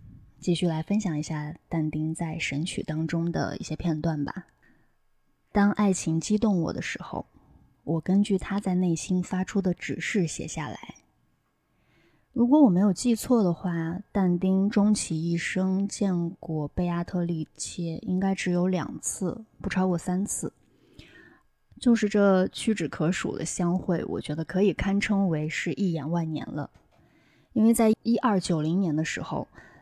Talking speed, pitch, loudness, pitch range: 225 characters per minute, 180 Hz, -27 LUFS, 165-200 Hz